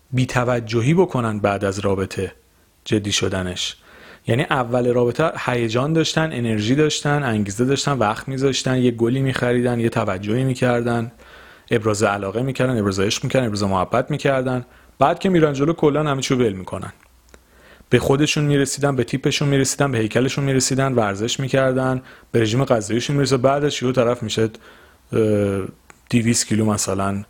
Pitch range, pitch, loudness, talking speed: 110-135 Hz, 125 Hz, -20 LUFS, 145 wpm